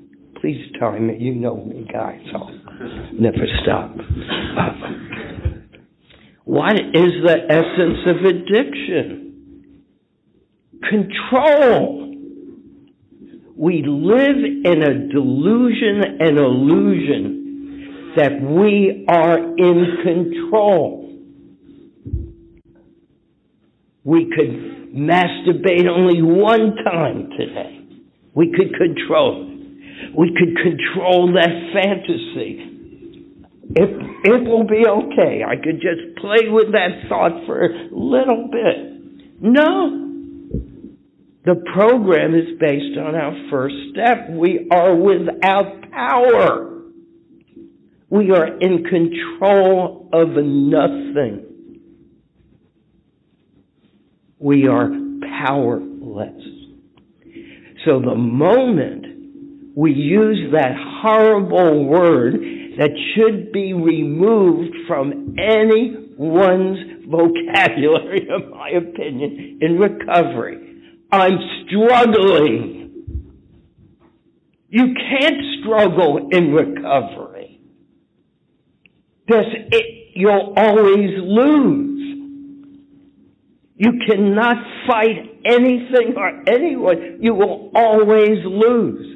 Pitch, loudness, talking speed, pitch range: 210 Hz, -16 LUFS, 85 wpm, 170-280 Hz